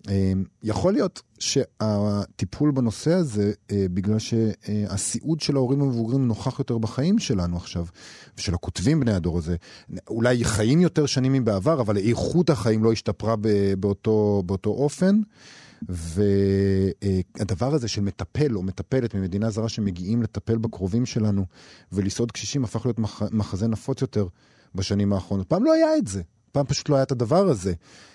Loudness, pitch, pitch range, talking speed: -24 LUFS, 110 Hz, 100-130 Hz, 140 wpm